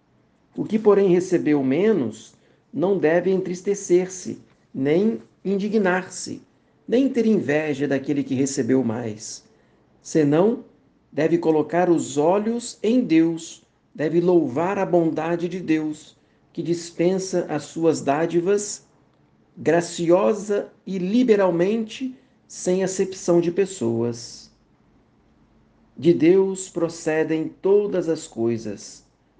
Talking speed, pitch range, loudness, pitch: 100 wpm, 155-195 Hz, -22 LUFS, 175 Hz